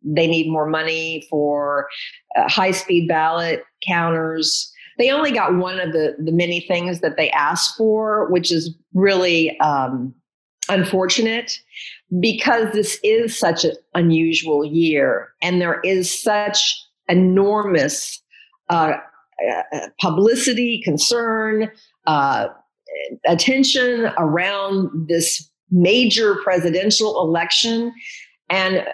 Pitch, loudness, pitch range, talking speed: 185 Hz, -18 LUFS, 165-220 Hz, 105 wpm